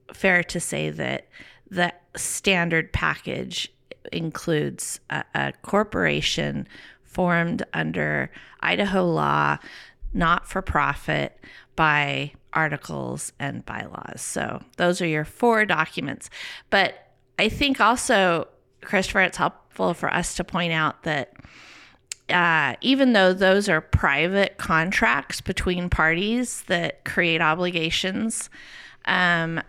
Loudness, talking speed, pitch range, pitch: -23 LUFS, 110 wpm, 155-190 Hz, 175 Hz